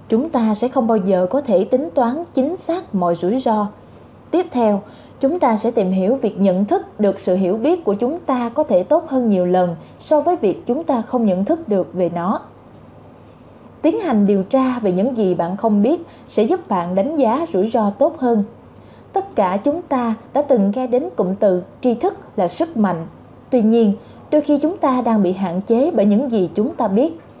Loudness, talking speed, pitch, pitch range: -18 LUFS, 215 wpm, 230 Hz, 200-280 Hz